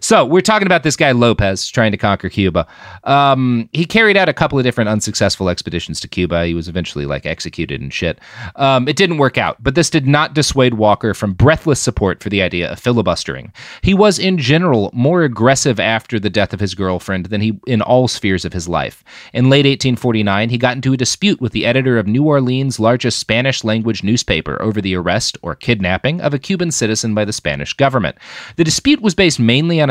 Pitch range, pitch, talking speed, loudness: 100-140 Hz, 120 Hz, 215 wpm, -15 LUFS